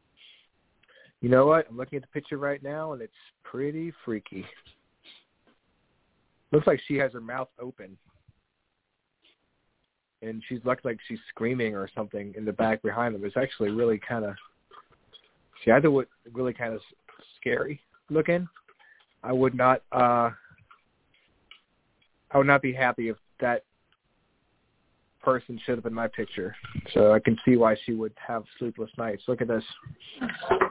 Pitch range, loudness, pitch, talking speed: 115-135 Hz, -27 LUFS, 125 Hz, 150 wpm